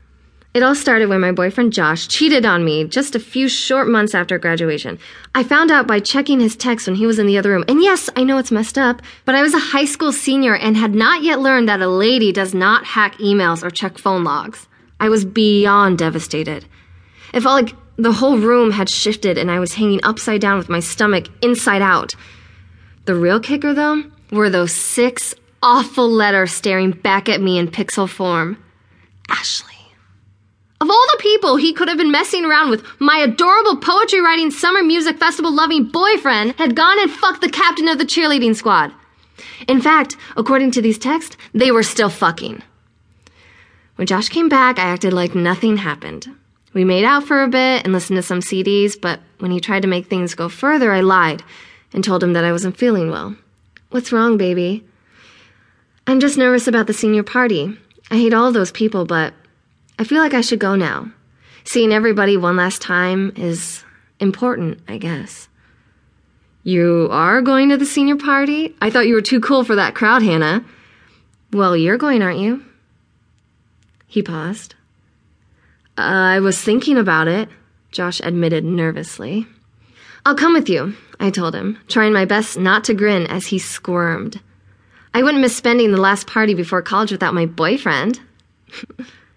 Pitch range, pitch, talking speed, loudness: 180-255 Hz, 210 Hz, 185 wpm, -15 LUFS